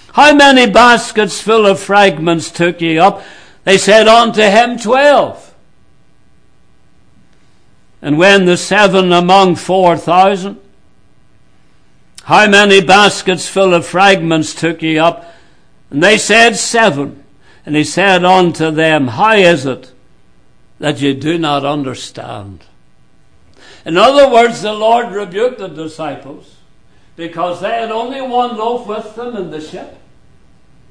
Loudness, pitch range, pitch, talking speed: -10 LUFS, 160-220 Hz, 190 Hz, 130 wpm